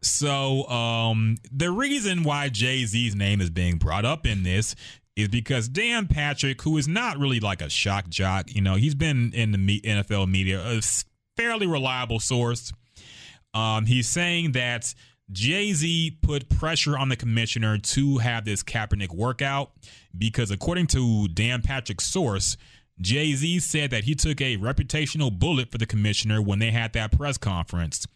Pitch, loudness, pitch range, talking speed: 115 Hz, -24 LUFS, 105-140 Hz, 165 wpm